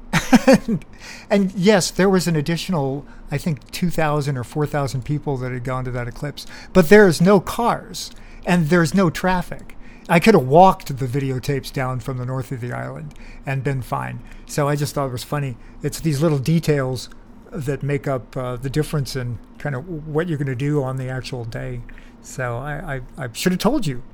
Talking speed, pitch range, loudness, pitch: 200 wpm, 130-170 Hz, -20 LUFS, 145 Hz